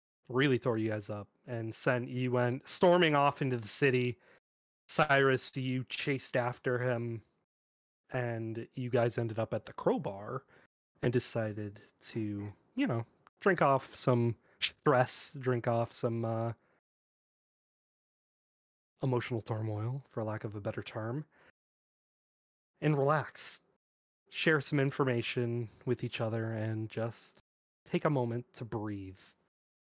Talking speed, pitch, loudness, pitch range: 125 wpm, 120 Hz, -33 LUFS, 110-130 Hz